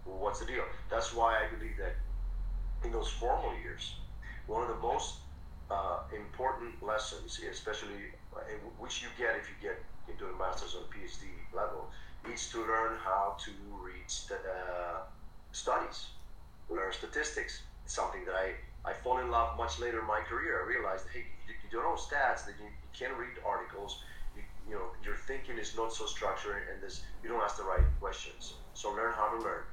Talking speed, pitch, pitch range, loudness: 190 wpm, 100 Hz, 75-115 Hz, -37 LUFS